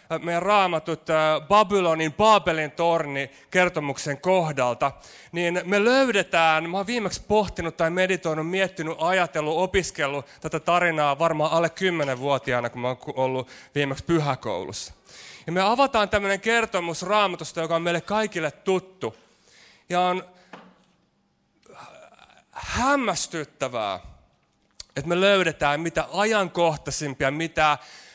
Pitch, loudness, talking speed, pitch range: 165 Hz, -23 LUFS, 110 wpm, 145-185 Hz